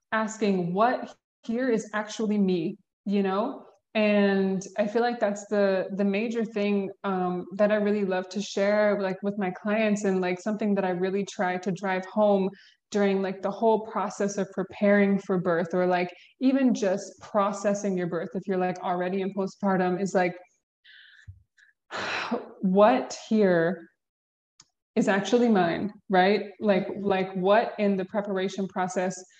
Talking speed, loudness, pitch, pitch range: 155 wpm, -26 LUFS, 195 Hz, 185-210 Hz